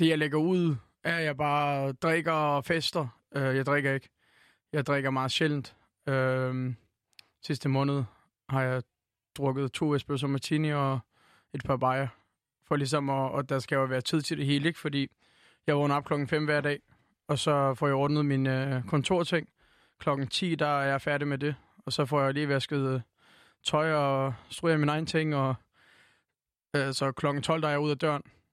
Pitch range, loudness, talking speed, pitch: 135-150 Hz, -29 LUFS, 190 wpm, 140 Hz